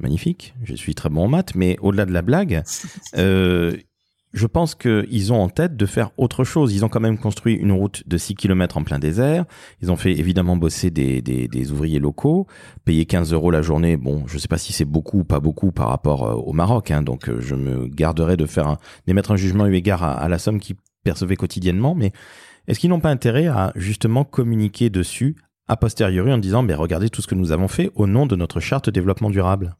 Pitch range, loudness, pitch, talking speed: 85-115 Hz, -20 LUFS, 95 Hz, 230 wpm